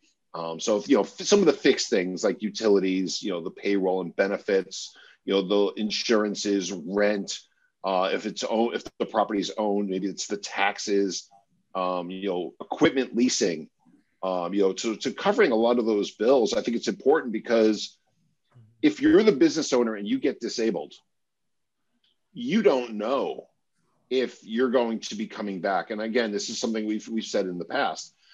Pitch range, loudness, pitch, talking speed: 100-125 Hz, -25 LUFS, 105 Hz, 185 wpm